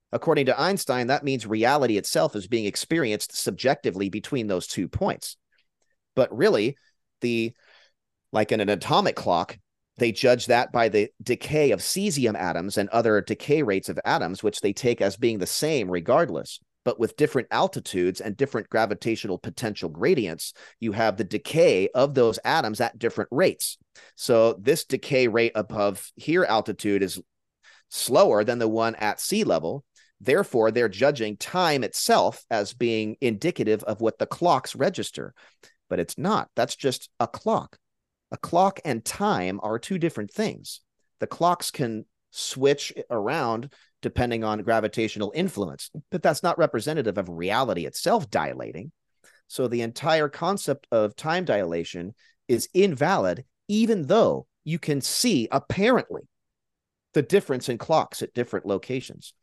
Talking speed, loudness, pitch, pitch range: 150 wpm, -25 LUFS, 120 Hz, 110-145 Hz